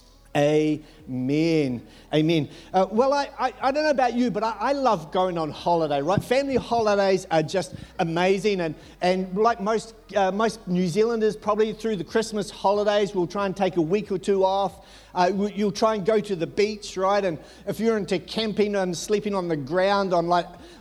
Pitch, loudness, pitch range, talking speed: 195 Hz, -24 LUFS, 175-215 Hz, 195 wpm